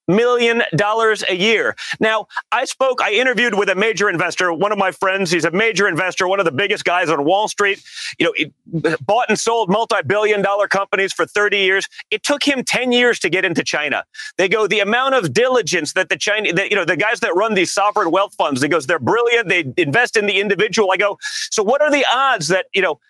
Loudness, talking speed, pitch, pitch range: -16 LUFS, 230 wpm, 210 Hz, 195-240 Hz